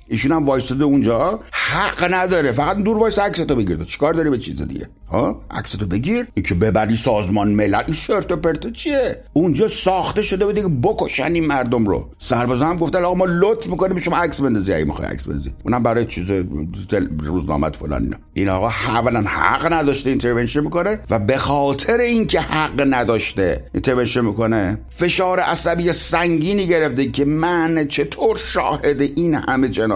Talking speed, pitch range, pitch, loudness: 165 wpm, 110-175 Hz, 140 Hz, -18 LUFS